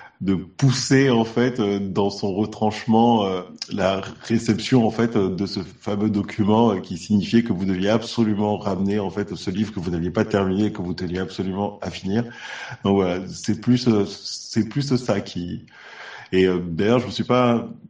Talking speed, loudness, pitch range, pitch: 200 wpm, -22 LUFS, 95-115 Hz, 105 Hz